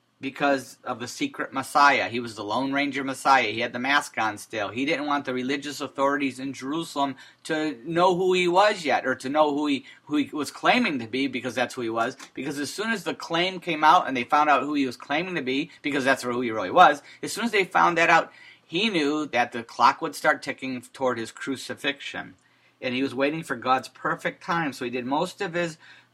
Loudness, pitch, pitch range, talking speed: -24 LUFS, 140 Hz, 130-155 Hz, 235 wpm